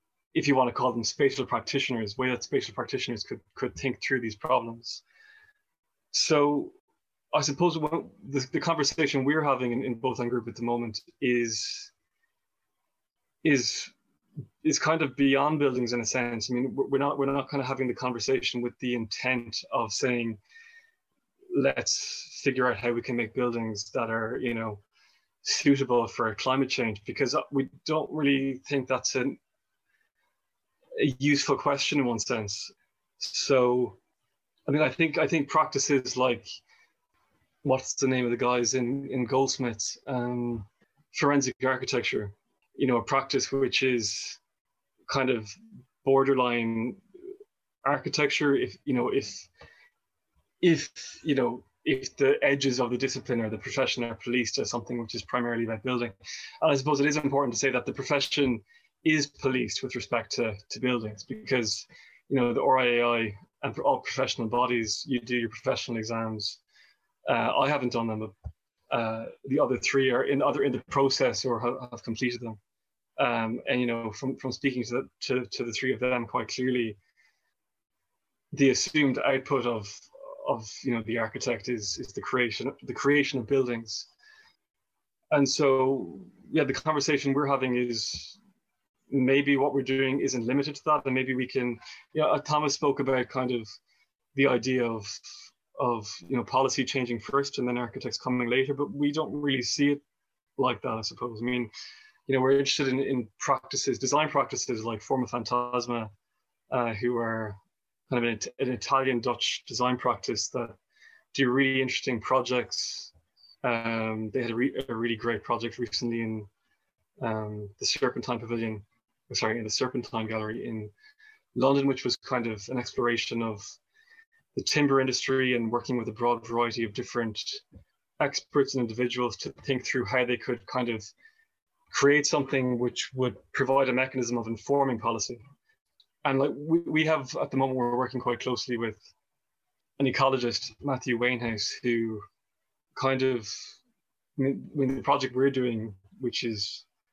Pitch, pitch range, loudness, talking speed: 125 Hz, 120-140 Hz, -28 LUFS, 165 wpm